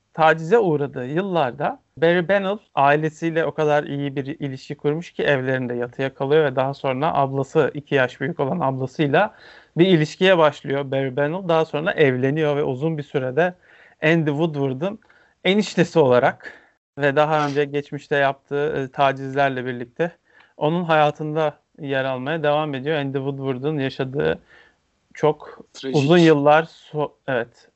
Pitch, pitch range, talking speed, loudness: 145 Hz, 135-160 Hz, 135 wpm, -21 LUFS